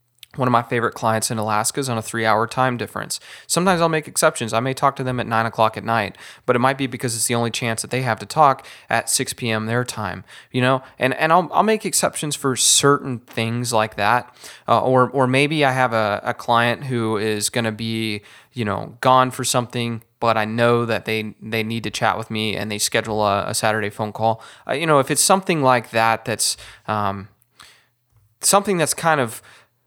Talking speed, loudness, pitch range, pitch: 225 wpm, -20 LUFS, 110-130 Hz, 115 Hz